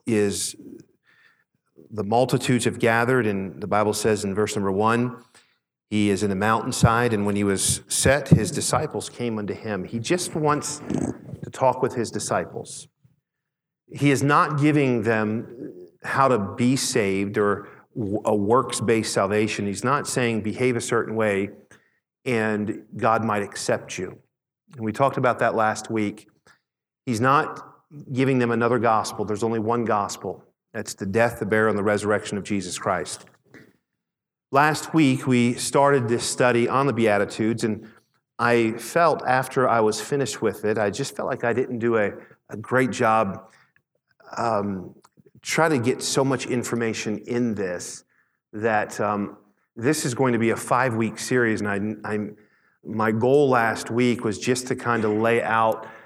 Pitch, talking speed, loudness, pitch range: 115 Hz, 165 wpm, -23 LUFS, 105-125 Hz